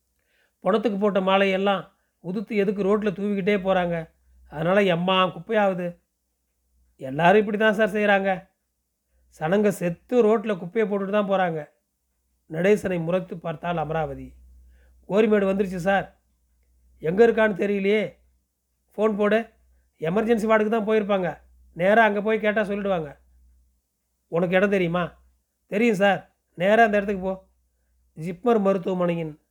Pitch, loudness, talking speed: 185 Hz, -23 LUFS, 110 wpm